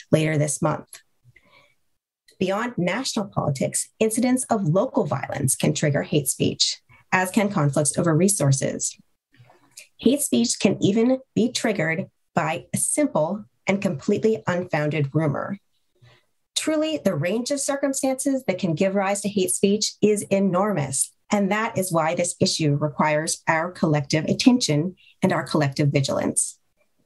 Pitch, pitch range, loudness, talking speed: 190 Hz, 155-220 Hz, -22 LUFS, 135 wpm